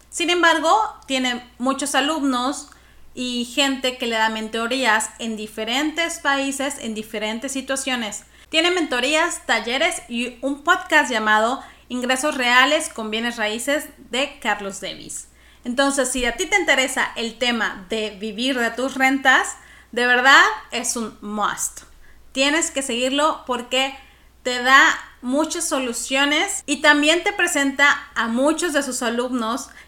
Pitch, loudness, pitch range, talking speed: 265 Hz, -19 LUFS, 235-295 Hz, 135 wpm